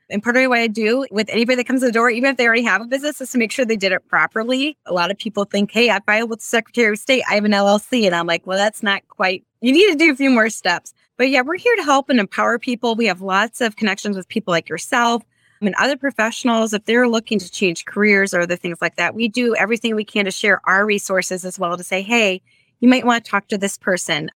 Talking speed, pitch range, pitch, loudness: 285 wpm, 190-240 Hz, 220 Hz, -17 LUFS